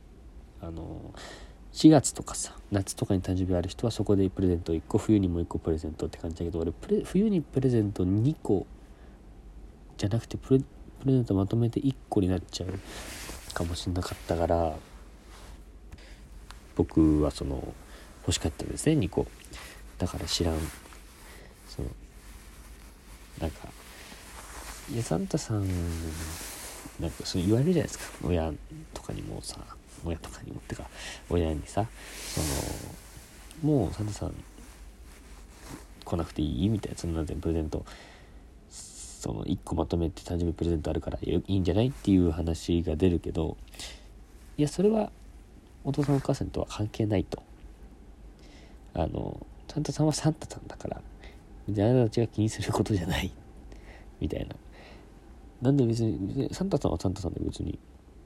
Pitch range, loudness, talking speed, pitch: 80-105 Hz, -29 LUFS, 300 characters per minute, 90 Hz